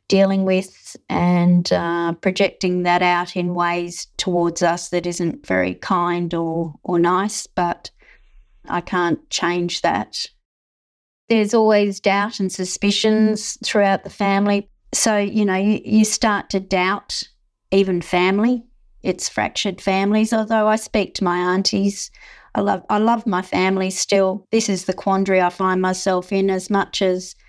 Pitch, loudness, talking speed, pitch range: 190 Hz, -19 LUFS, 150 wpm, 175-205 Hz